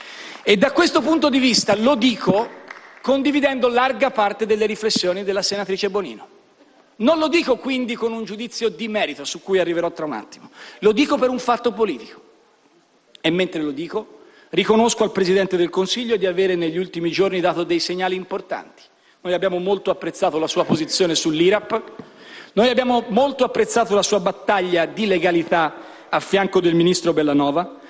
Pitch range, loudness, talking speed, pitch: 180-250 Hz, -19 LUFS, 165 wpm, 205 Hz